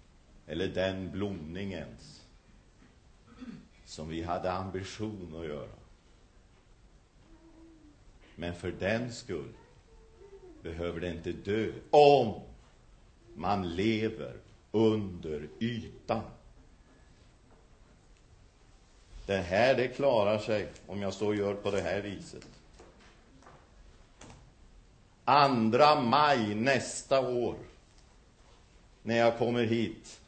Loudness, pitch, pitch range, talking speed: -30 LUFS, 100 Hz, 85-115 Hz, 85 wpm